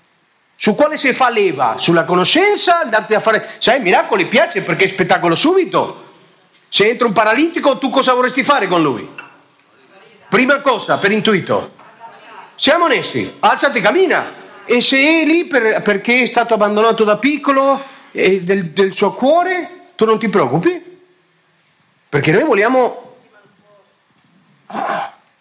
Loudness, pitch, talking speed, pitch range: -13 LUFS, 245 Hz, 135 wpm, 210-305 Hz